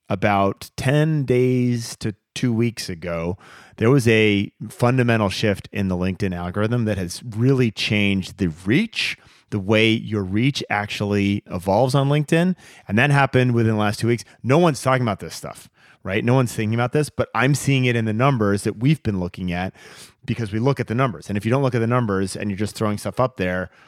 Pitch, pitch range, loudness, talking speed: 110 Hz, 100-125 Hz, -21 LUFS, 210 wpm